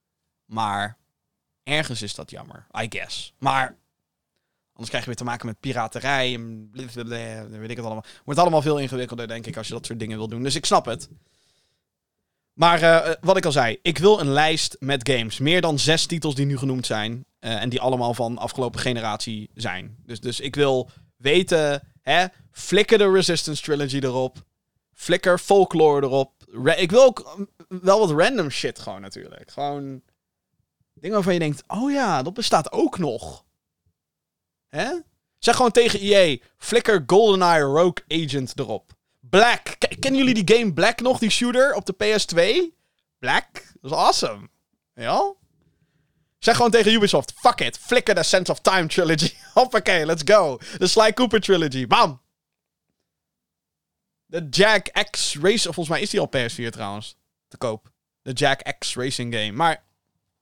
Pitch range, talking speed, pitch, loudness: 125-195 Hz, 165 wpm, 150 Hz, -21 LUFS